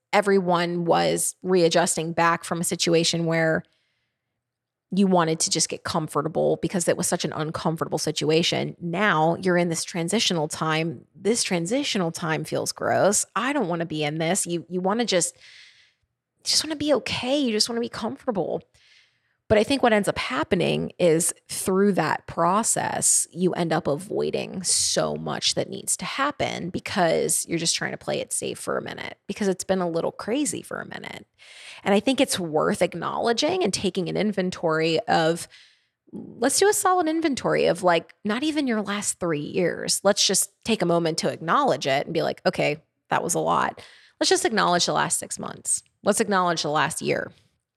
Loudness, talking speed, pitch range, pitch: -23 LUFS, 185 wpm, 165-210 Hz, 180 Hz